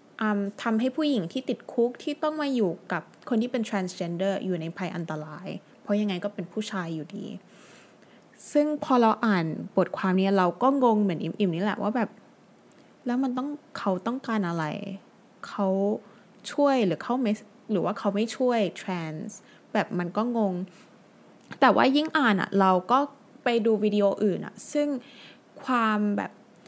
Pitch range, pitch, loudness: 190-245 Hz, 210 Hz, -27 LUFS